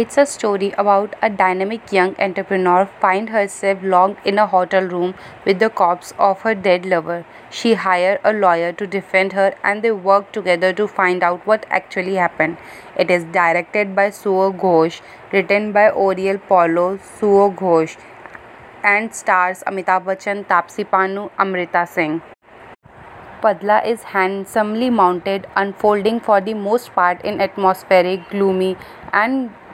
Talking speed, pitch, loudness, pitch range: 140 wpm, 195 Hz, -17 LUFS, 185-205 Hz